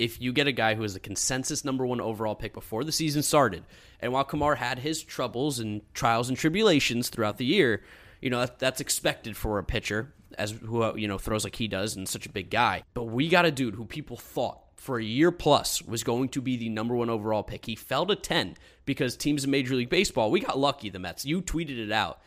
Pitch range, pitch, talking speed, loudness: 110-140 Hz, 120 Hz, 240 wpm, -28 LUFS